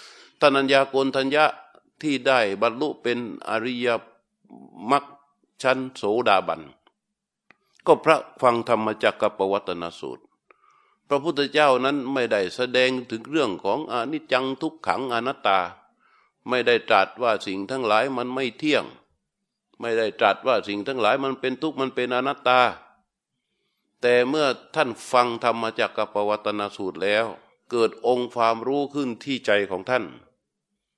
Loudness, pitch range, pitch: -23 LUFS, 115-135 Hz, 125 Hz